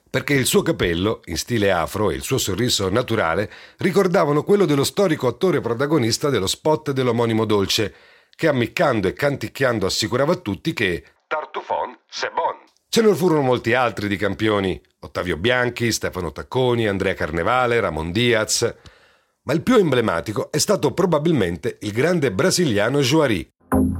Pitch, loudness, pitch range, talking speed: 125 Hz, -20 LUFS, 110-155 Hz, 150 wpm